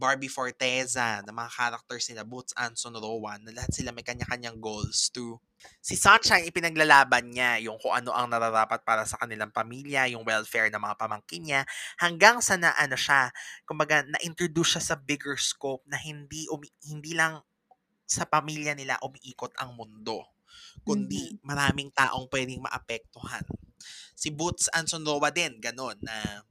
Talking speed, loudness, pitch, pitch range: 160 wpm, -27 LUFS, 130 Hz, 115-150 Hz